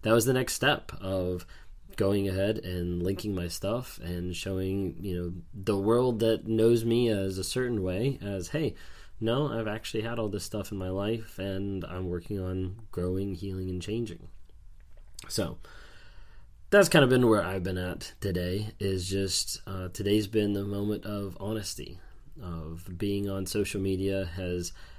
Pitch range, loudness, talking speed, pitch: 90-110 Hz, -30 LUFS, 170 wpm, 95 Hz